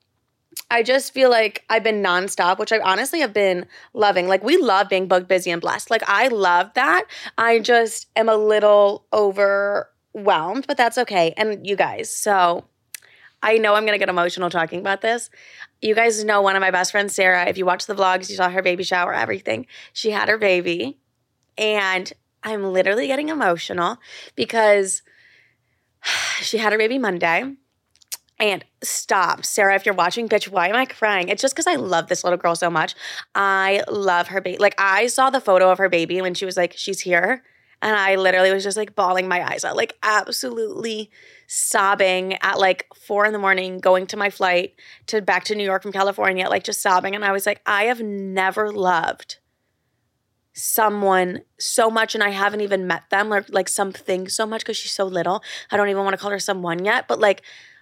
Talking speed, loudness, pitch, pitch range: 200 wpm, -19 LUFS, 200 Hz, 185-215 Hz